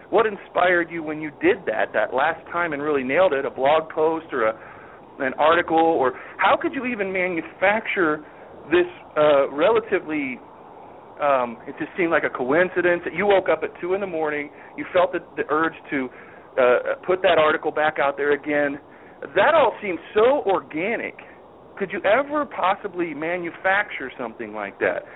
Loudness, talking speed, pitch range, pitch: -22 LUFS, 175 wpm, 155-205 Hz, 175 Hz